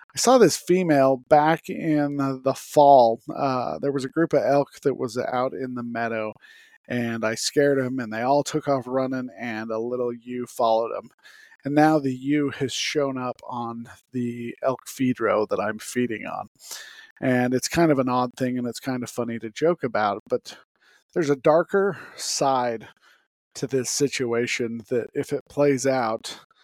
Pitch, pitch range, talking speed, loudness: 130 Hz, 120-145 Hz, 185 wpm, -23 LUFS